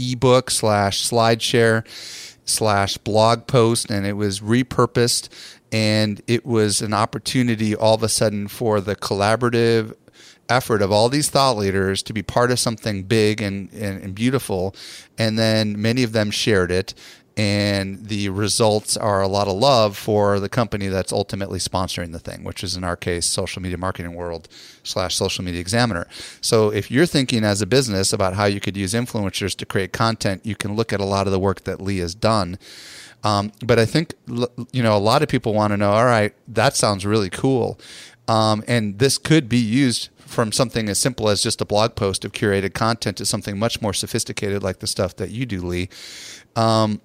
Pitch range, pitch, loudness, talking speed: 100-115 Hz, 110 Hz, -20 LUFS, 195 wpm